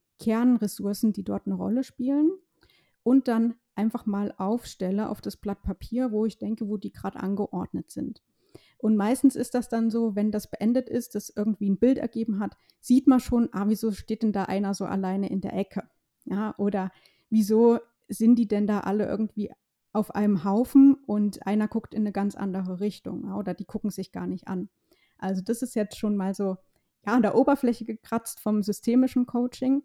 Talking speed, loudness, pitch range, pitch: 195 wpm, -26 LUFS, 200-235 Hz, 215 Hz